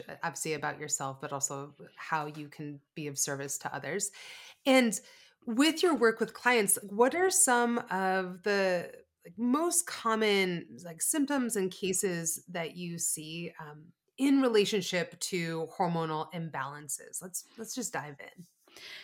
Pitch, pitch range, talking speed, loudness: 185 Hz, 160-245 Hz, 140 wpm, -30 LUFS